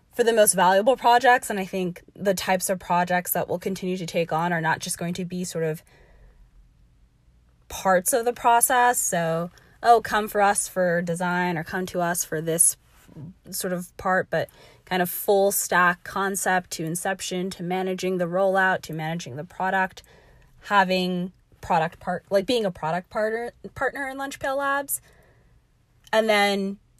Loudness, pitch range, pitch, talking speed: -23 LUFS, 170-200 Hz, 185 Hz, 170 wpm